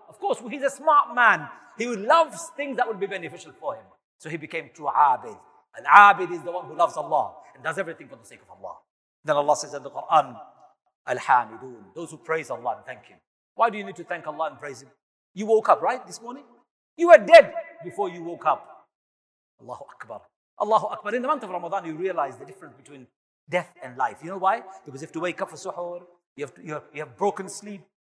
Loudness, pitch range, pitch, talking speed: -22 LUFS, 160-240 Hz, 185 Hz, 230 wpm